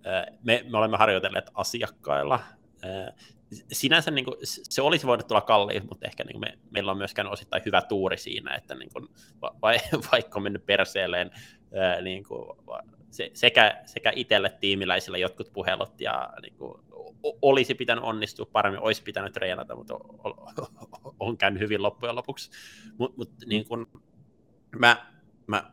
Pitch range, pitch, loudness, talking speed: 100-120 Hz, 110 Hz, -26 LUFS, 150 wpm